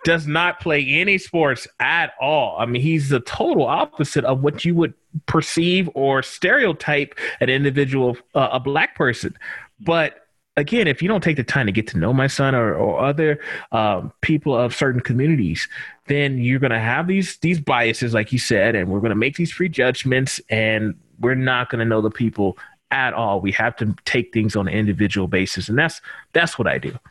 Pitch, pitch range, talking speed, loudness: 130 Hz, 115-155 Hz, 215 wpm, -19 LUFS